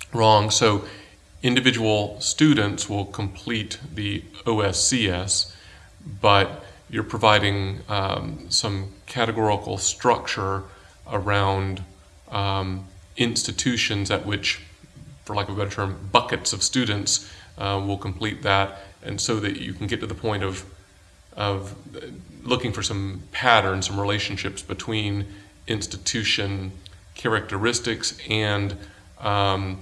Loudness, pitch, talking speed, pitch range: -23 LUFS, 100 Hz, 110 wpm, 95-110 Hz